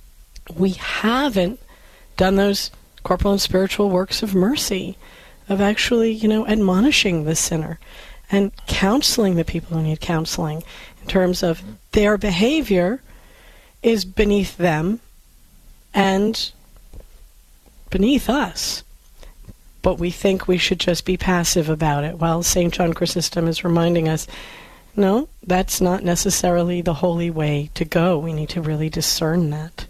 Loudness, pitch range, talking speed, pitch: -19 LUFS, 165-200 Hz, 135 wpm, 180 Hz